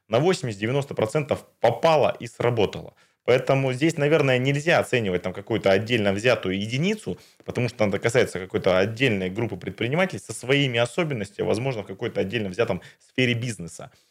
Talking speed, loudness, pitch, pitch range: 145 wpm, -24 LUFS, 120 Hz, 105-140 Hz